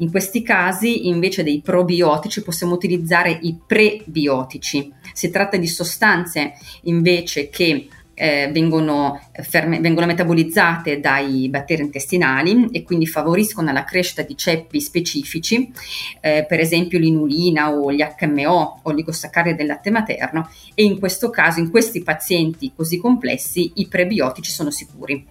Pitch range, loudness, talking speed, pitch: 150-180 Hz, -18 LUFS, 135 wpm, 170 Hz